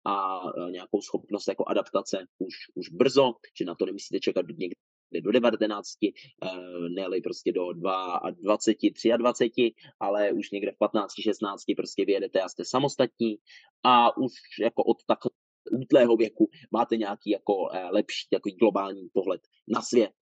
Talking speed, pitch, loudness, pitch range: 145 wpm, 110 Hz, -27 LUFS, 95-115 Hz